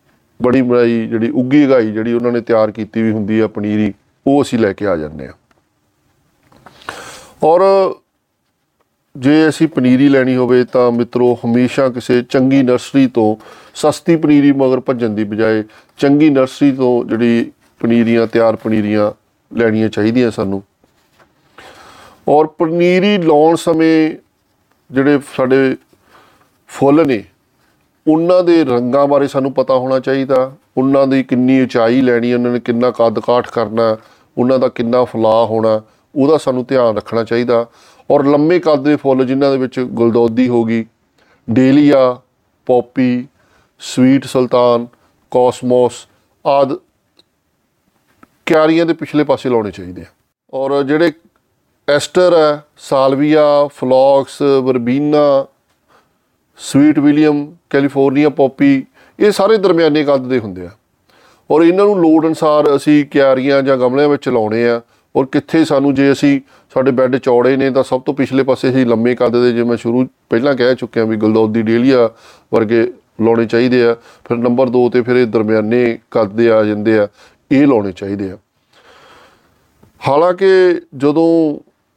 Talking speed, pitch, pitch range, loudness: 140 wpm, 130 Hz, 115-145 Hz, -13 LUFS